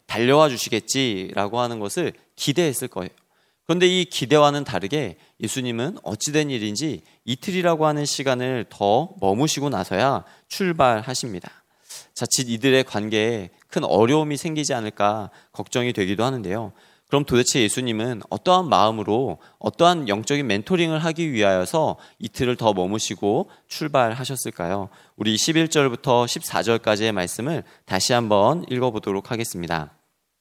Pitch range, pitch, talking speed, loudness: 105-145 Hz, 120 Hz, 330 characters per minute, -22 LUFS